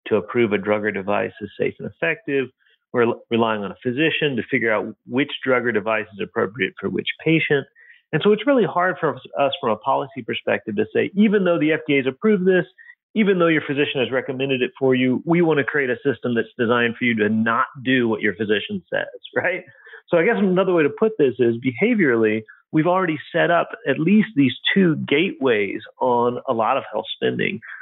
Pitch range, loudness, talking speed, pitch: 120-175 Hz, -20 LUFS, 215 wpm, 140 Hz